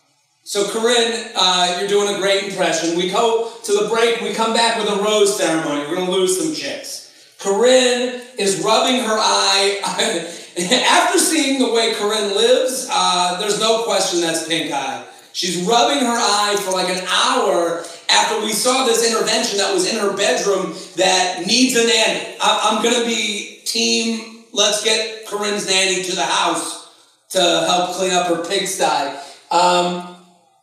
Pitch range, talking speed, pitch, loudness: 185-230 Hz, 165 wpm, 205 Hz, -17 LUFS